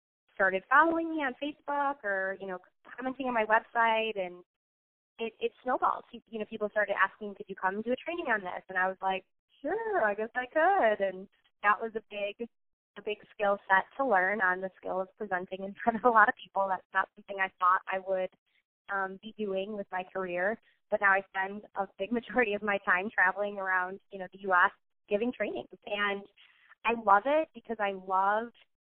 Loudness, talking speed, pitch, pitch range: -30 LUFS, 210 wpm, 205 Hz, 190-230 Hz